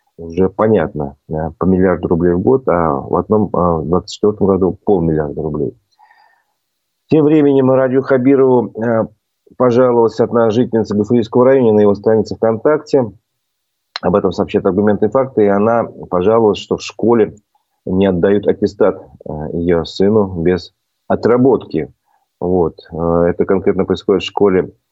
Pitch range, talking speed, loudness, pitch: 90-120 Hz, 130 wpm, -14 LUFS, 105 Hz